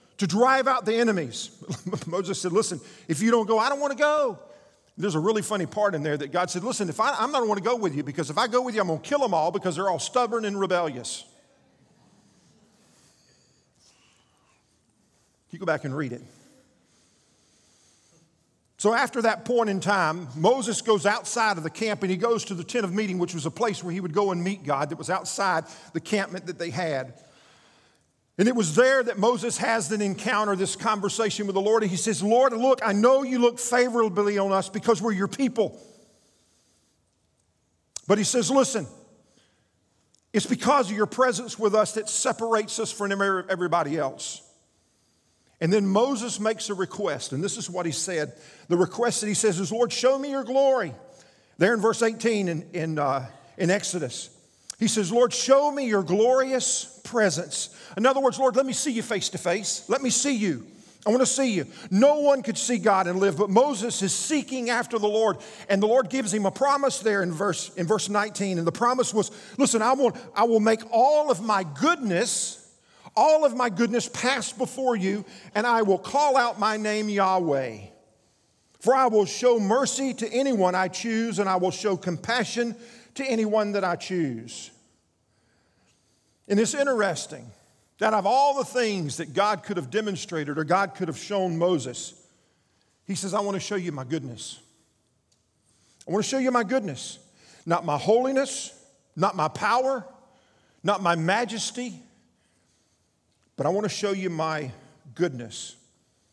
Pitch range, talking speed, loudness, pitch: 175-240 Hz, 185 wpm, -25 LUFS, 205 Hz